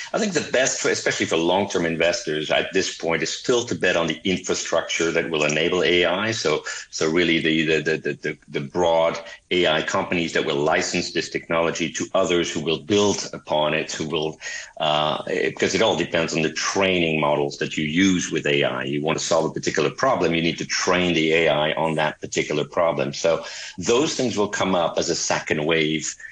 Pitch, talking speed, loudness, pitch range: 80 Hz, 200 wpm, -22 LUFS, 75-85 Hz